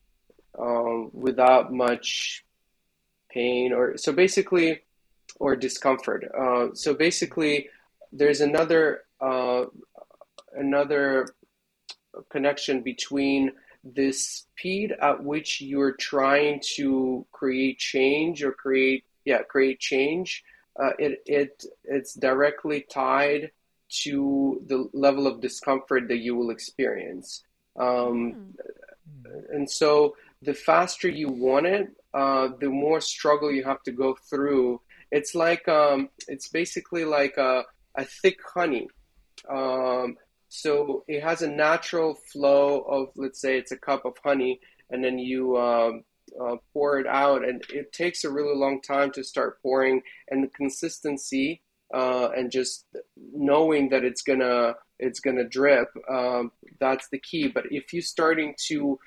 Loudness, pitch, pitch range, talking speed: -25 LUFS, 140 Hz, 130-150 Hz, 130 wpm